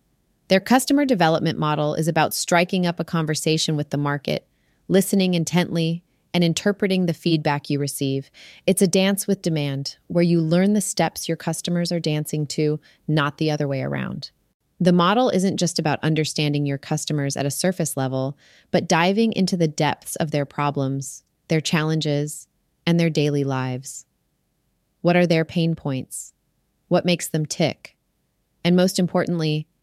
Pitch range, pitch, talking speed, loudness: 145-175 Hz, 160 Hz, 160 wpm, -22 LUFS